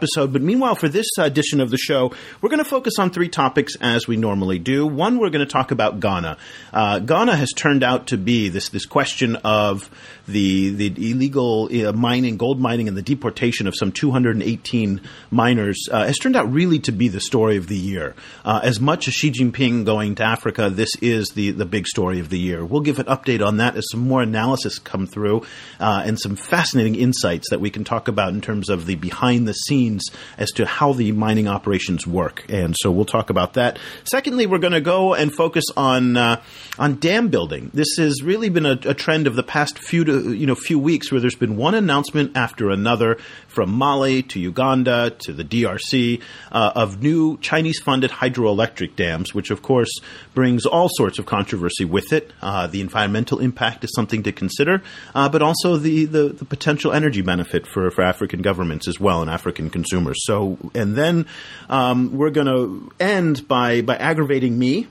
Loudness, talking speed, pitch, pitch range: -19 LUFS, 200 wpm, 120 Hz, 105-145 Hz